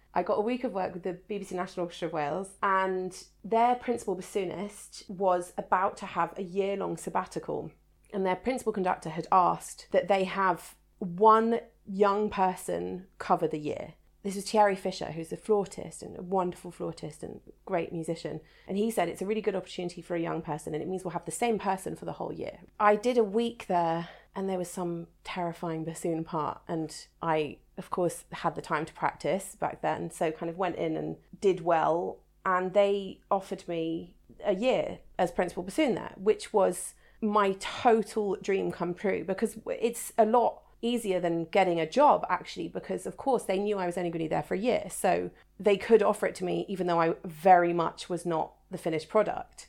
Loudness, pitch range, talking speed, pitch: -30 LUFS, 170-205 Hz, 200 wpm, 185 Hz